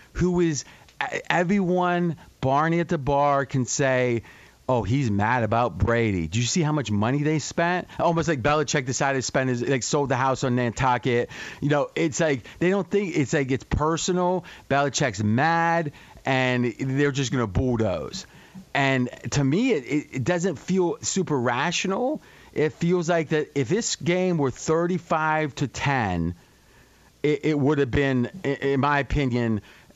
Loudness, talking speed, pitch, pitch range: -24 LUFS, 165 wpm, 140 Hz, 125-165 Hz